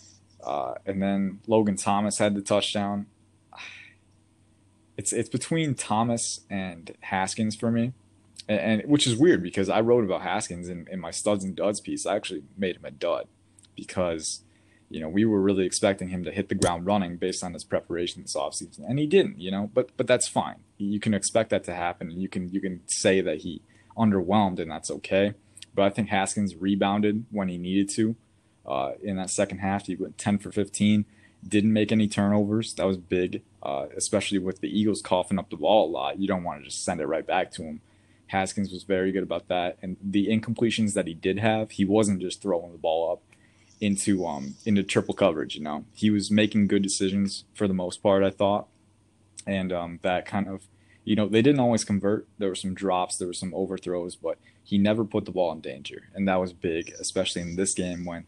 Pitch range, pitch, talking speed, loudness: 95-105 Hz, 100 Hz, 210 wpm, -26 LUFS